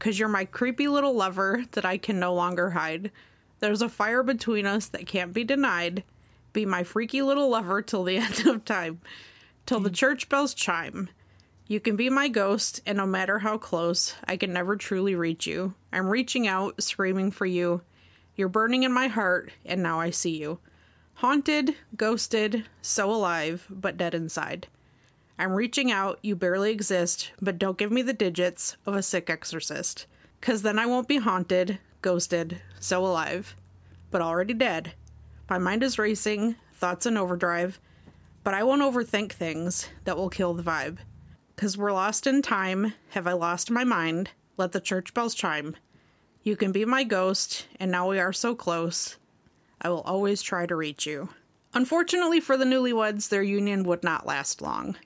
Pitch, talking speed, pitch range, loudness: 195 Hz, 180 wpm, 175-225 Hz, -27 LUFS